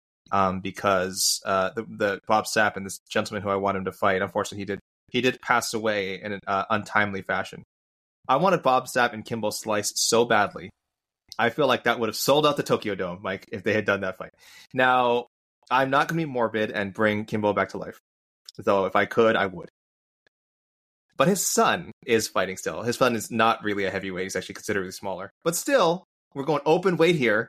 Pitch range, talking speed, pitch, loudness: 95-120 Hz, 215 wpm, 105 Hz, -24 LUFS